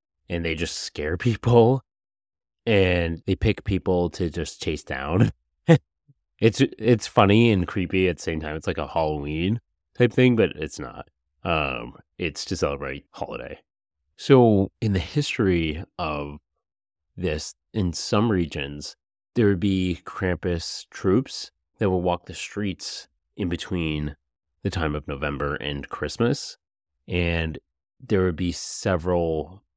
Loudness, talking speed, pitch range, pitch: -24 LUFS, 135 wpm, 75-100 Hz, 90 Hz